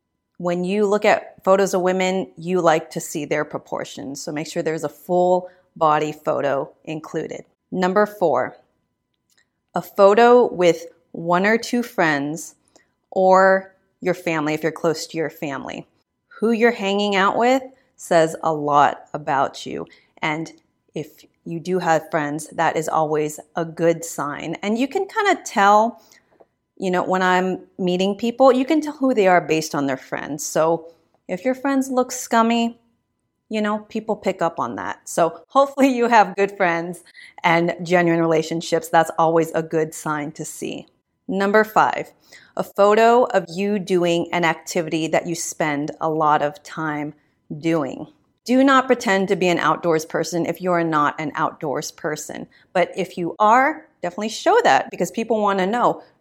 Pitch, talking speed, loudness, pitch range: 180 Hz, 165 wpm, -20 LUFS, 160-210 Hz